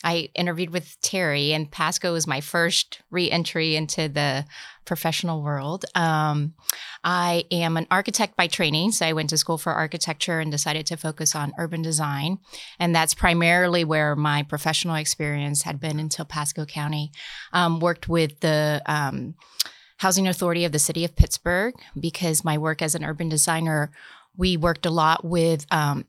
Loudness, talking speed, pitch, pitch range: -23 LUFS, 170 wpm, 165 Hz, 155-175 Hz